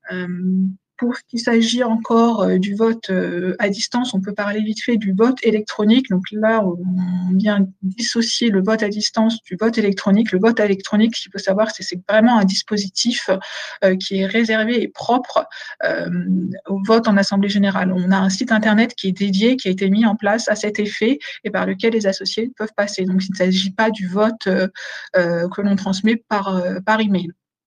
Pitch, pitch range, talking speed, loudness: 205 Hz, 190-225 Hz, 195 wpm, -18 LUFS